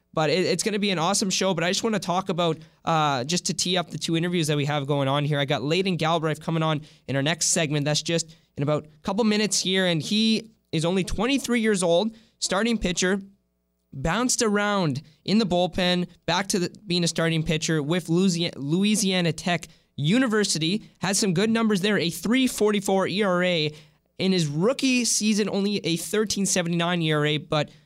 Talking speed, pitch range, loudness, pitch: 195 wpm, 160-205 Hz, -24 LUFS, 180 Hz